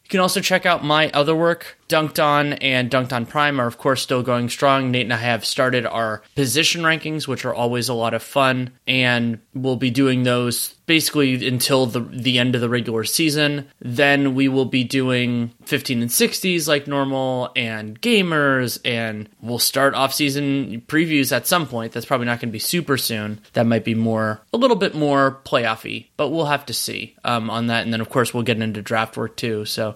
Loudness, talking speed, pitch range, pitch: -19 LUFS, 210 wpm, 120-145 Hz, 130 Hz